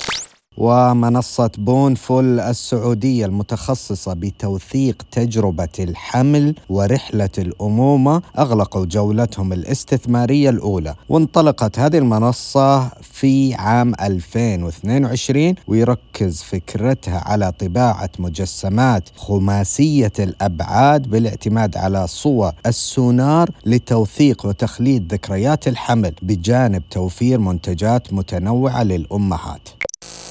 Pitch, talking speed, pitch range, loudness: 115 Hz, 75 wpm, 95-130 Hz, -17 LUFS